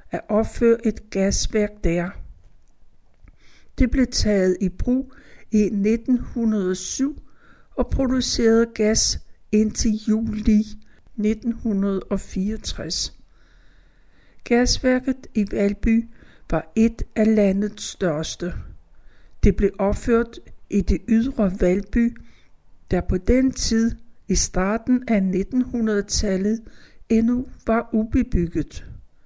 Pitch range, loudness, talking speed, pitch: 195-235 Hz, -22 LUFS, 90 wpm, 215 Hz